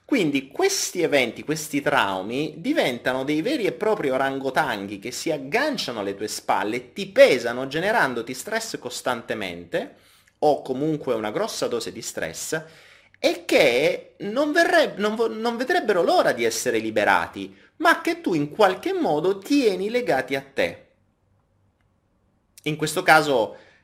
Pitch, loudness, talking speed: 155 Hz, -23 LUFS, 135 wpm